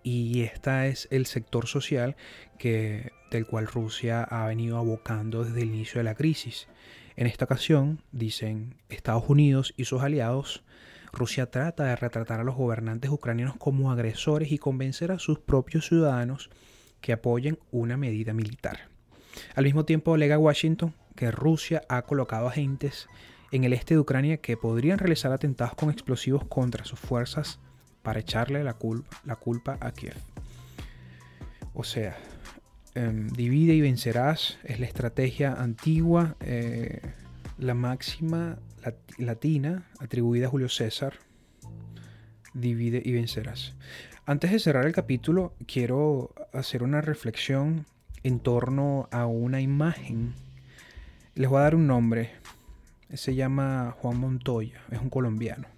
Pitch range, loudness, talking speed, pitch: 115-145 Hz, -28 LUFS, 140 wpm, 125 Hz